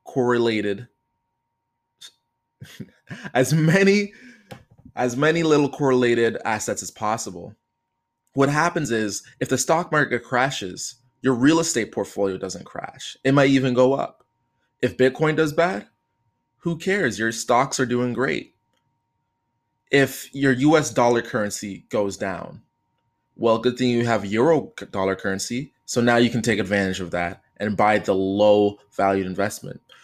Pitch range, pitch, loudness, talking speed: 105-135 Hz, 120 Hz, -21 LUFS, 140 wpm